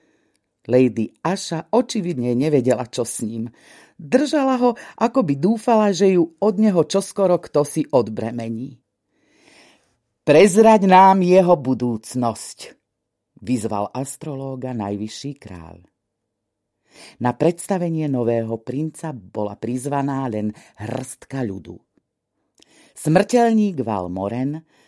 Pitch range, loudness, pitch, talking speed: 115-185 Hz, -19 LUFS, 135 Hz, 95 wpm